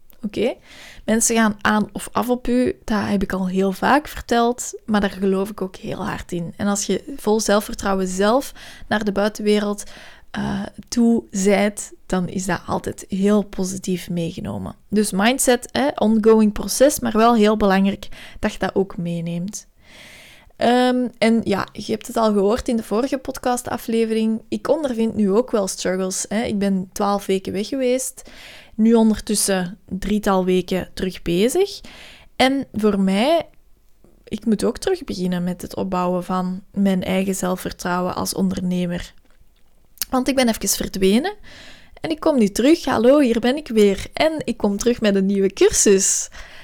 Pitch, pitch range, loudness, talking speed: 210 Hz, 195-235 Hz, -20 LUFS, 165 wpm